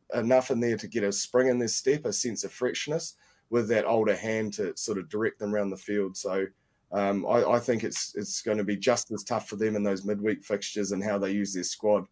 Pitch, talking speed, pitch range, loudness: 105 Hz, 255 wpm, 100-120 Hz, -28 LUFS